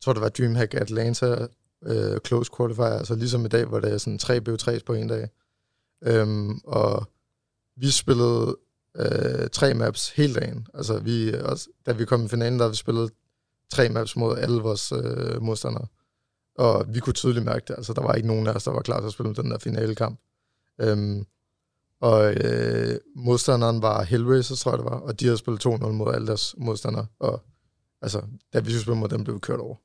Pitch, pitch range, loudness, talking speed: 115 Hz, 110-120 Hz, -25 LUFS, 210 wpm